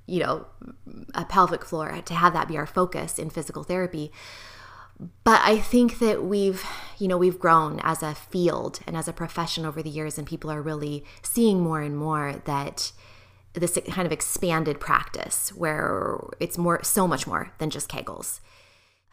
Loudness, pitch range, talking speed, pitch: -25 LUFS, 150-180 Hz, 175 wpm, 165 Hz